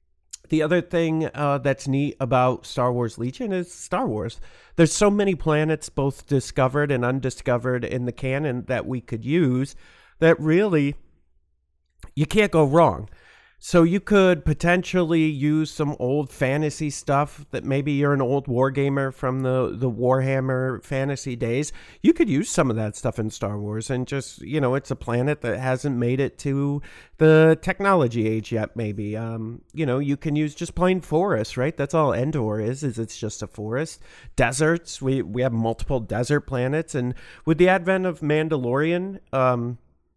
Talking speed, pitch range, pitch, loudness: 175 wpm, 125-155 Hz, 135 Hz, -23 LUFS